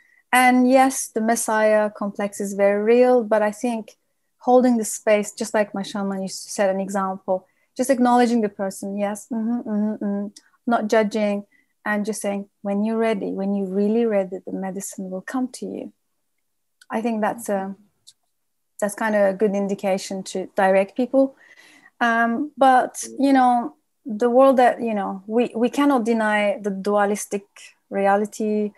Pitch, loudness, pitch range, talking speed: 215 Hz, -21 LUFS, 200-245 Hz, 165 wpm